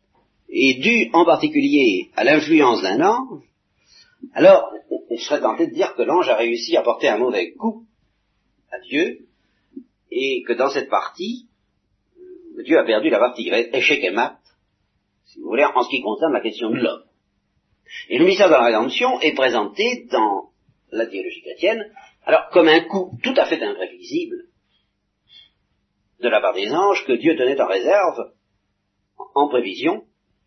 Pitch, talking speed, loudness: 290 Hz, 160 wpm, -18 LUFS